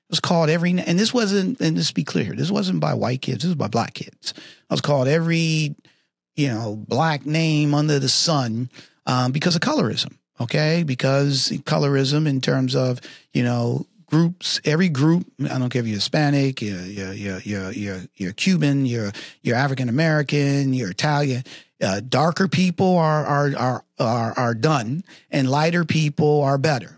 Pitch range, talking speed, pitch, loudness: 125-160 Hz, 175 wpm, 145 Hz, -21 LUFS